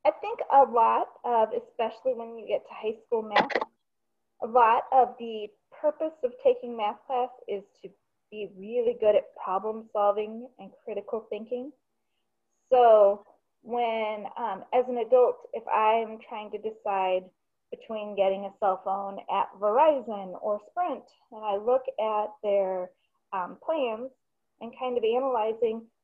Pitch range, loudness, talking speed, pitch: 210-255 Hz, -27 LUFS, 145 wpm, 225 Hz